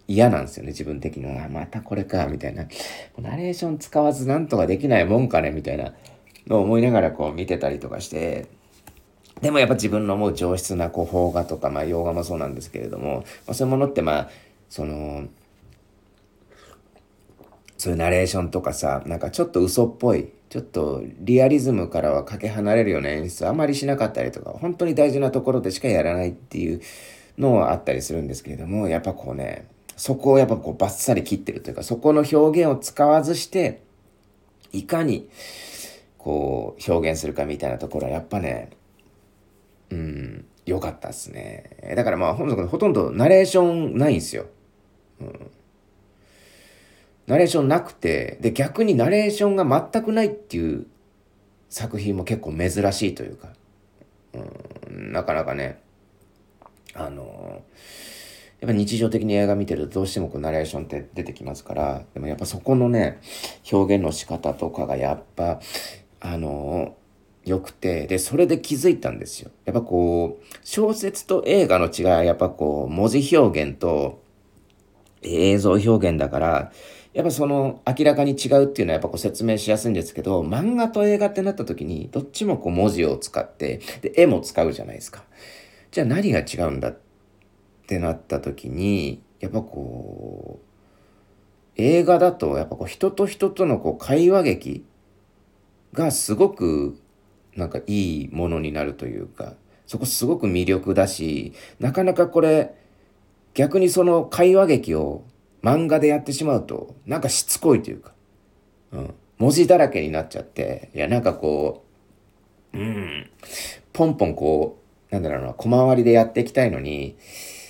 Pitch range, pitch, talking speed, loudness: 85-135 Hz, 100 Hz, 335 characters per minute, -22 LUFS